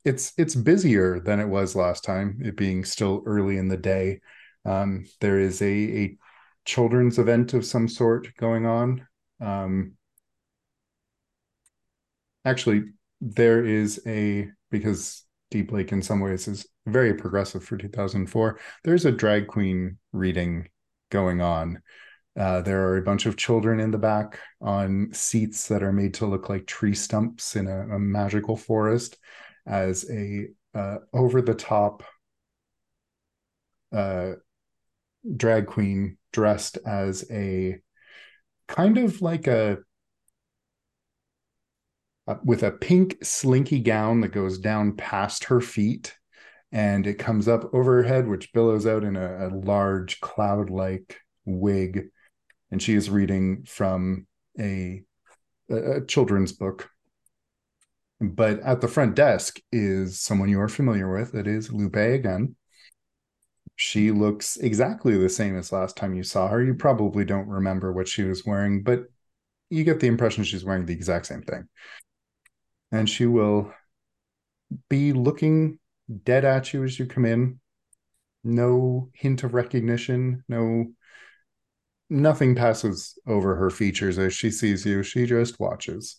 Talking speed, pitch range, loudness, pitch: 140 wpm, 95-120 Hz, -24 LUFS, 105 Hz